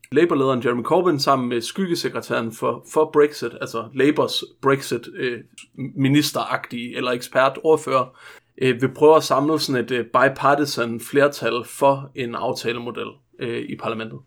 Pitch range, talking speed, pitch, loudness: 120-150 Hz, 130 wpm, 135 Hz, -21 LUFS